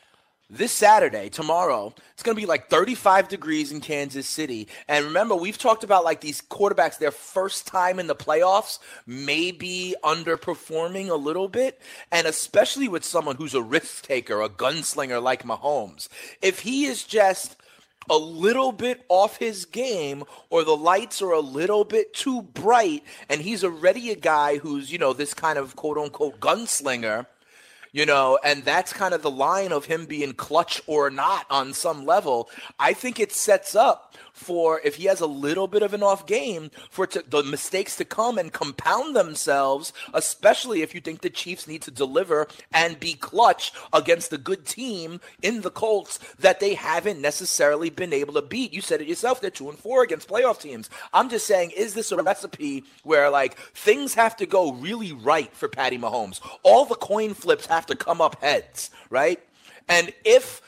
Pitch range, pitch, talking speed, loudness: 150-215 Hz, 180 Hz, 185 wpm, -23 LUFS